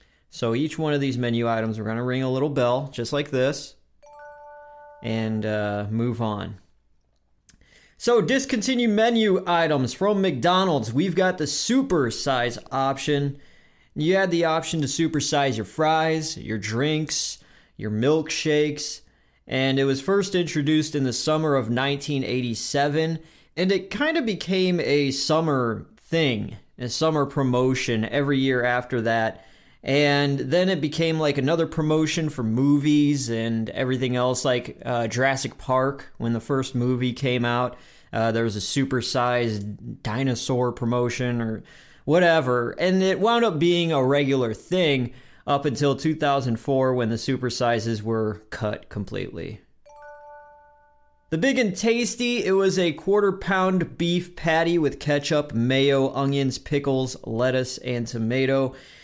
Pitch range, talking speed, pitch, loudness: 120-165 Hz, 140 wpm, 140 Hz, -23 LUFS